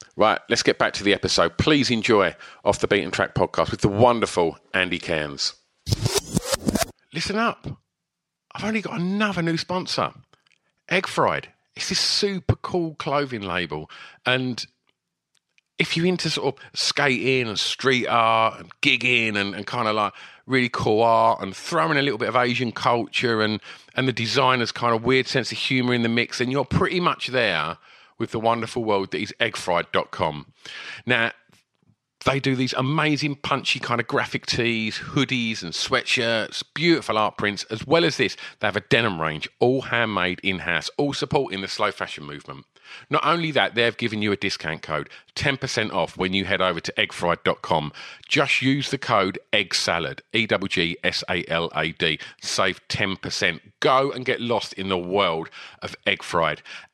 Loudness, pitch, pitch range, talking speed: -22 LUFS, 120 Hz, 100-140 Hz, 165 wpm